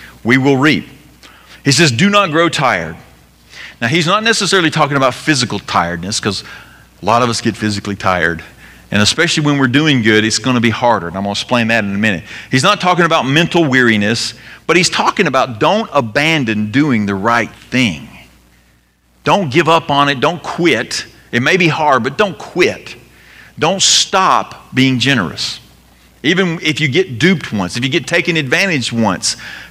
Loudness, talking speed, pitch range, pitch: -13 LUFS, 185 wpm, 105-155 Hz, 125 Hz